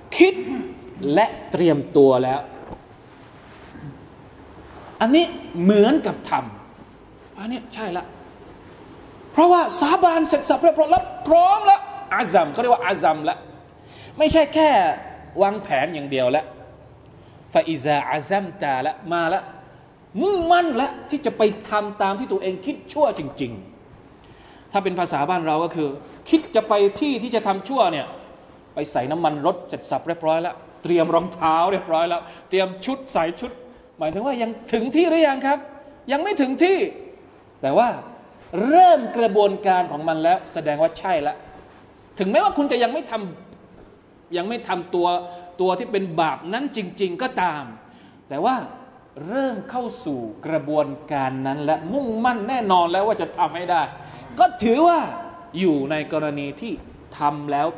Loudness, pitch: -21 LUFS, 210 Hz